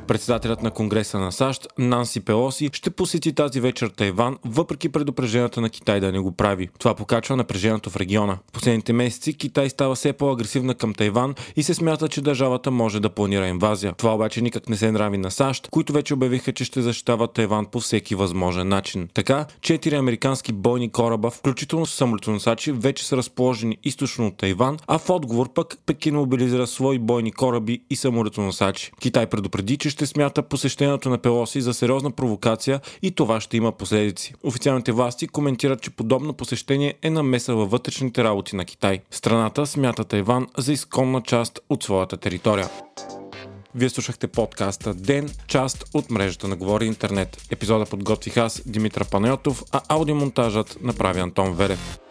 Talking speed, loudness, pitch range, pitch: 165 wpm, -23 LUFS, 105-135 Hz, 120 Hz